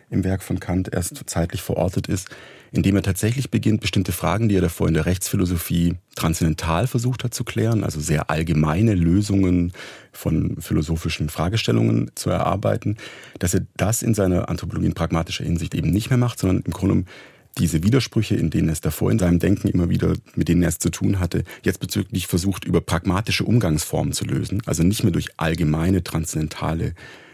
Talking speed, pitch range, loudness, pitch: 180 wpm, 85-105 Hz, -22 LUFS, 95 Hz